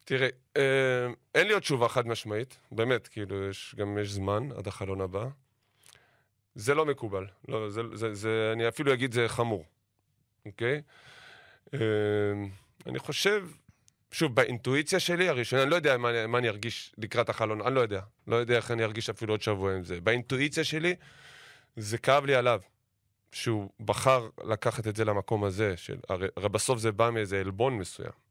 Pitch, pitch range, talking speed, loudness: 115 Hz, 105-130 Hz, 170 wpm, -29 LUFS